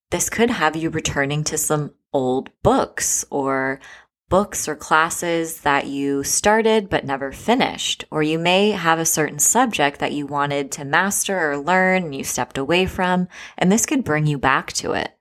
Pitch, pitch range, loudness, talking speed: 155 Hz, 140-185 Hz, -19 LUFS, 180 wpm